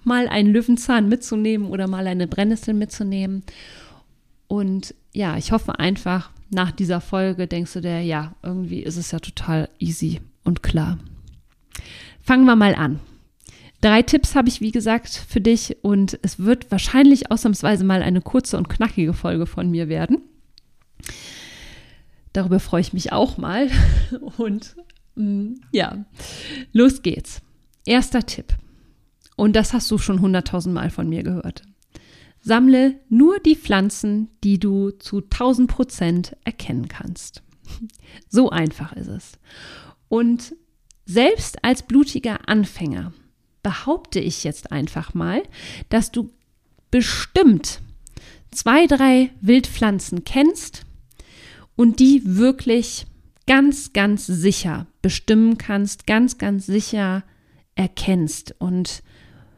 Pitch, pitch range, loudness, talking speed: 205 Hz, 180-240 Hz, -19 LUFS, 120 wpm